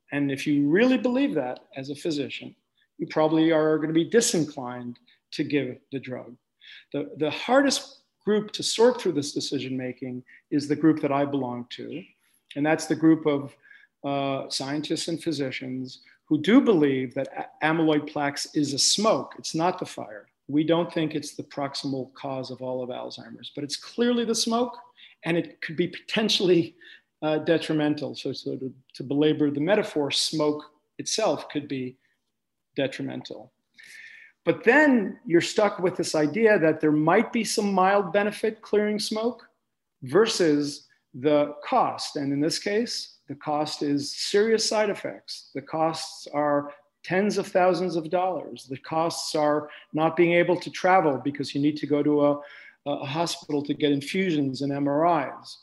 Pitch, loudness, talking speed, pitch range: 155 Hz, -25 LUFS, 165 wpm, 140-185 Hz